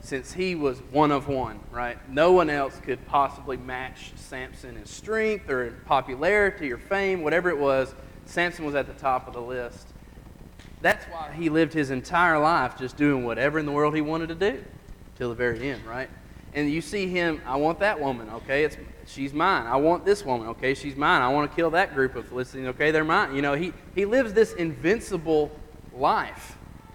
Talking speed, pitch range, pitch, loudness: 205 wpm, 130-165 Hz, 145 Hz, -25 LUFS